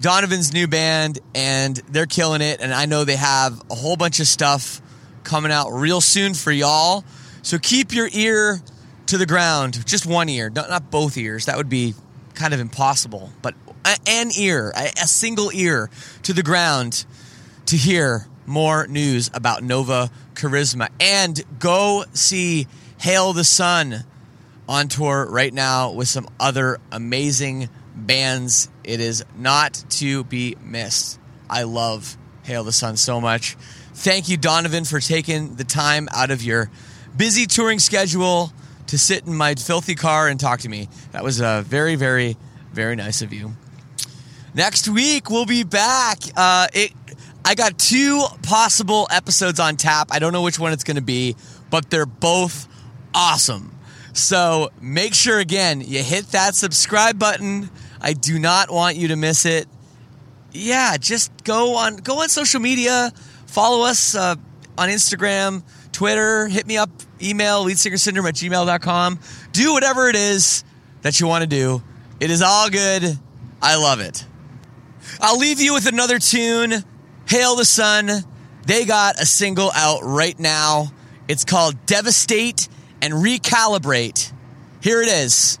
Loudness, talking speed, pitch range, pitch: -17 LUFS, 155 wpm, 130-195 Hz, 155 Hz